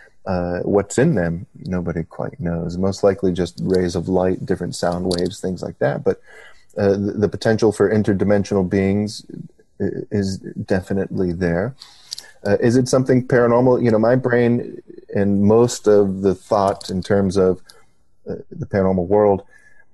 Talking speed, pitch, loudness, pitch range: 150 wpm, 100 Hz, -19 LUFS, 90-110 Hz